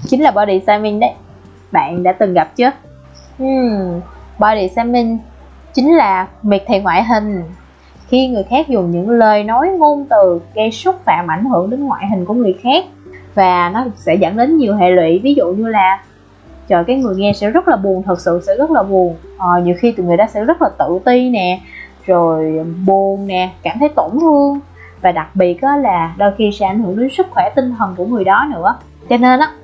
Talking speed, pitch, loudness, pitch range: 215 wpm, 210 Hz, -13 LUFS, 185-265 Hz